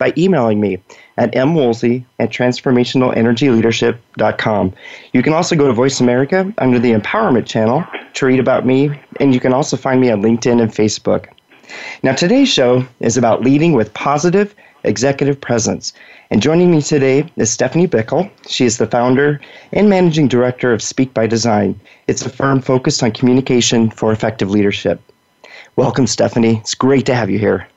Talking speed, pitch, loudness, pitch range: 165 wpm, 125 Hz, -14 LUFS, 115-140 Hz